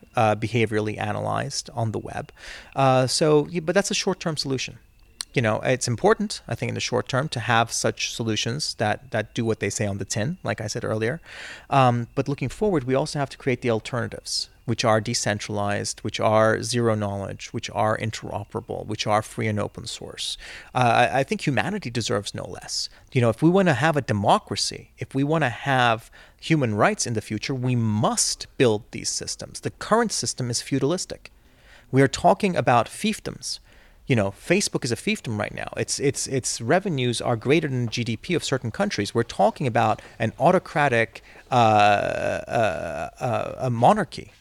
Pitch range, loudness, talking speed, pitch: 110-140 Hz, -24 LUFS, 190 wpm, 120 Hz